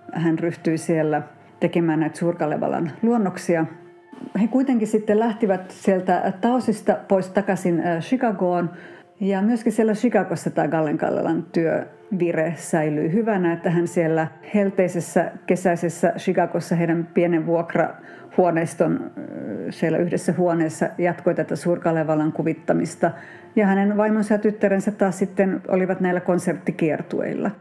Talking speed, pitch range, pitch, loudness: 115 wpm, 170-205 Hz, 180 Hz, -22 LUFS